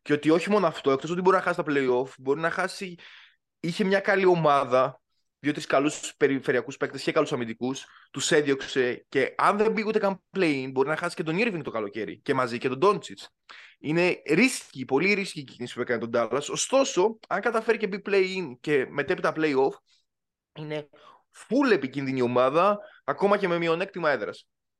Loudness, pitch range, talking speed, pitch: -25 LUFS, 140-195 Hz, 185 wpm, 165 Hz